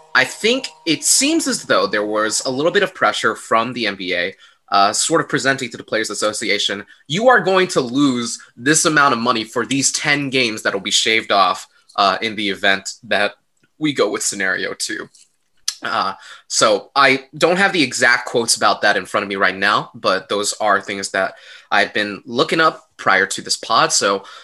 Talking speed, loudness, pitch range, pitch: 200 wpm, -17 LUFS, 110-160 Hz, 135 Hz